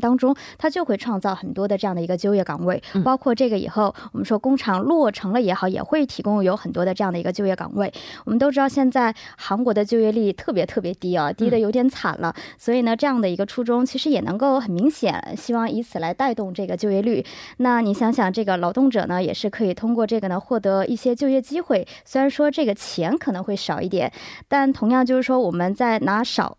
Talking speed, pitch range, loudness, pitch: 355 characters per minute, 195-255 Hz, -21 LUFS, 225 Hz